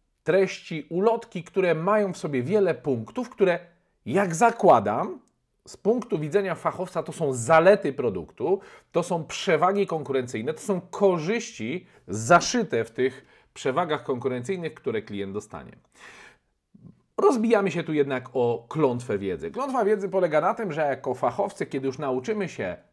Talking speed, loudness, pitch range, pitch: 140 wpm, -25 LUFS, 135-205 Hz, 175 Hz